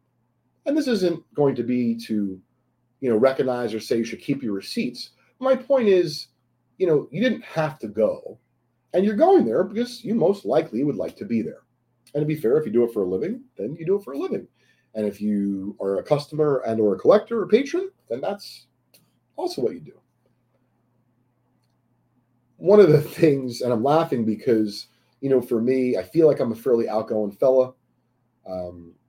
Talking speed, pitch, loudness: 200 wpm, 130 Hz, -22 LUFS